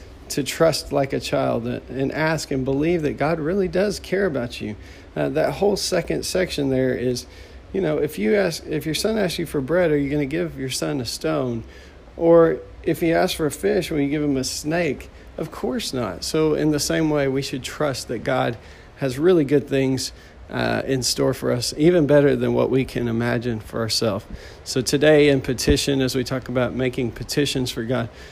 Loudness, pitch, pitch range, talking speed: -21 LUFS, 135 Hz, 125-155 Hz, 210 wpm